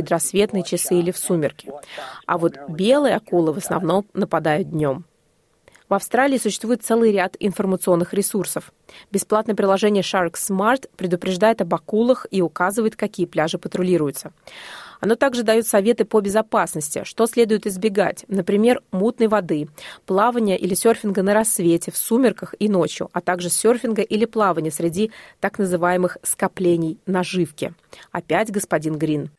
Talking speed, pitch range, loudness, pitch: 135 wpm, 175-220 Hz, -20 LUFS, 195 Hz